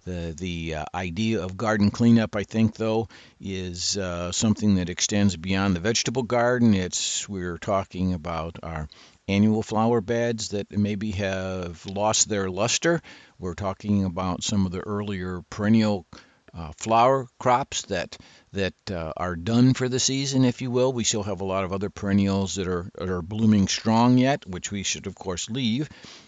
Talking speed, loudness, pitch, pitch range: 175 wpm, -24 LUFS, 100 Hz, 90-110 Hz